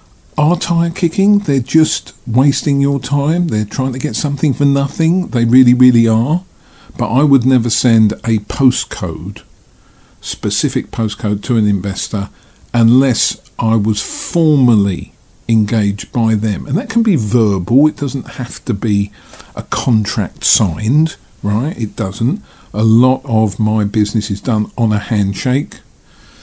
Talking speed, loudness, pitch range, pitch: 145 wpm, -14 LUFS, 105-140 Hz, 115 Hz